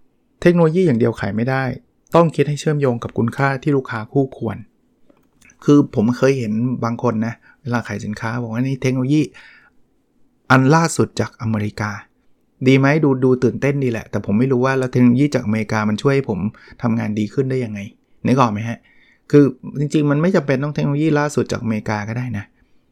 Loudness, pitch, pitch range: -18 LUFS, 125 Hz, 115-140 Hz